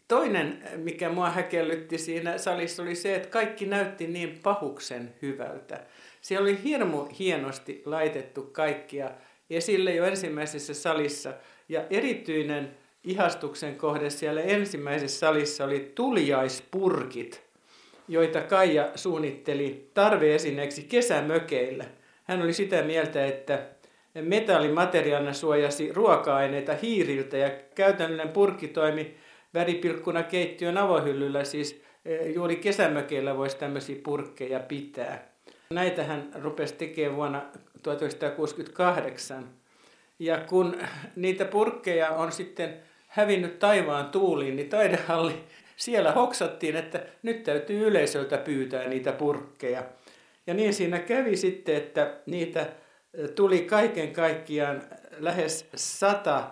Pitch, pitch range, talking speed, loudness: 160 Hz, 145-180 Hz, 105 wpm, -28 LUFS